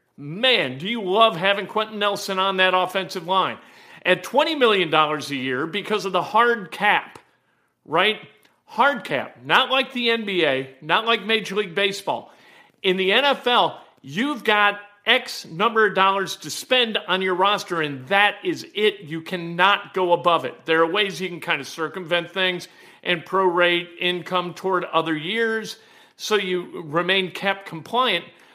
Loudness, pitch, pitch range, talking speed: -21 LUFS, 190 Hz, 175-215 Hz, 160 wpm